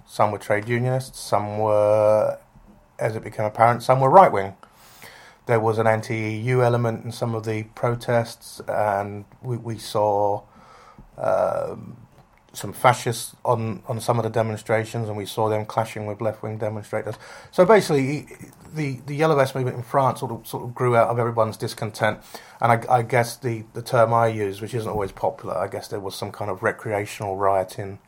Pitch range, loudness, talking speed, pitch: 110-120 Hz, -22 LUFS, 185 wpm, 115 Hz